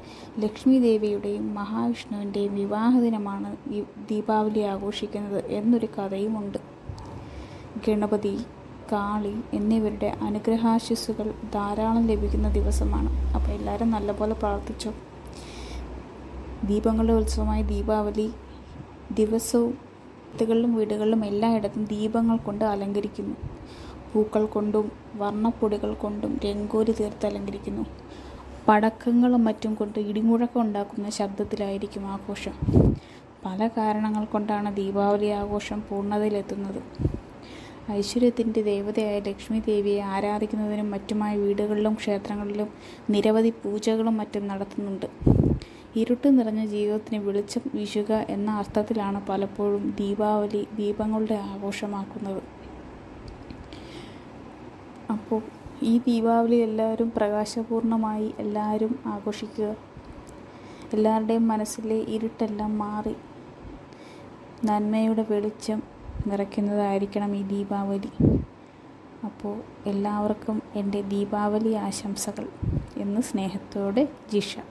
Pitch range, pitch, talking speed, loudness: 205-225 Hz, 210 Hz, 80 wpm, -26 LUFS